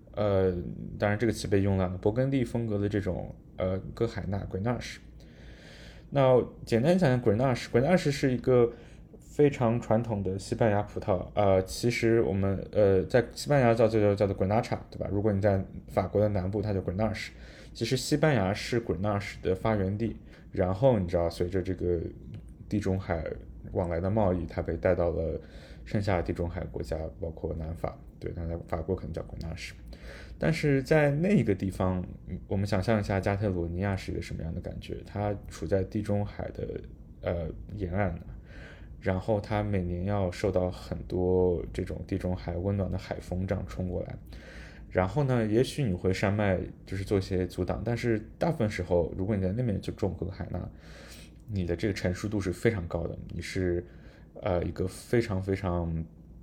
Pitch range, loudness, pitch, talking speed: 90-110 Hz, -29 LUFS, 95 Hz, 305 characters per minute